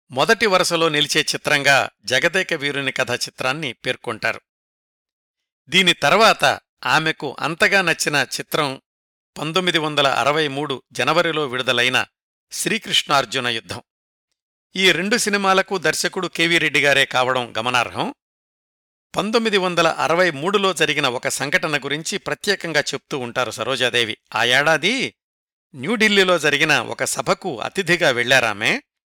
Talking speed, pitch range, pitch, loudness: 105 wpm, 130-180 Hz, 150 Hz, -18 LUFS